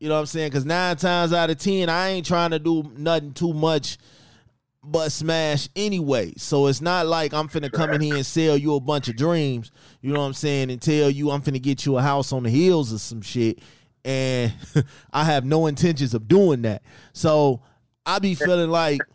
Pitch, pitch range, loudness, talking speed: 150 Hz, 135-165 Hz, -22 LUFS, 225 wpm